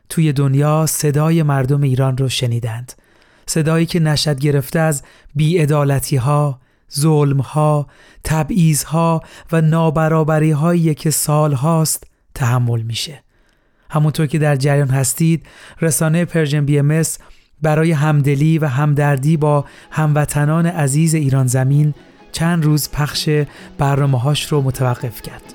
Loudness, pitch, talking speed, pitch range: -16 LUFS, 150 Hz, 115 wpm, 140-160 Hz